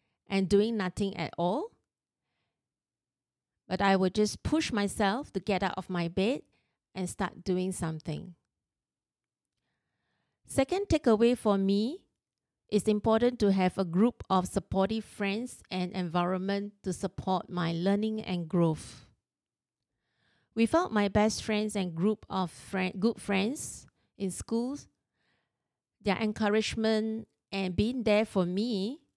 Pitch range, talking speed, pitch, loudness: 185-220 Hz, 125 wpm, 200 Hz, -30 LUFS